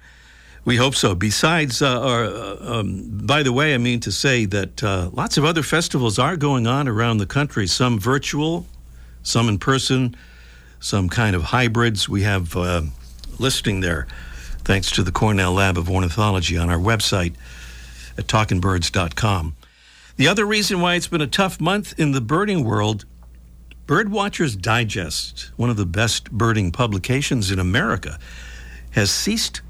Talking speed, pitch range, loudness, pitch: 160 wpm, 85-130 Hz, -20 LUFS, 105 Hz